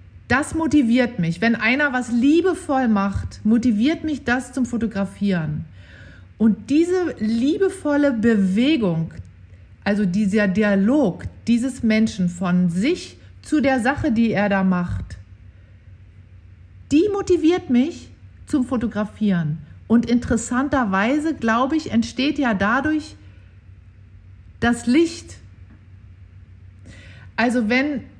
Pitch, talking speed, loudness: 225 Hz, 100 wpm, -20 LUFS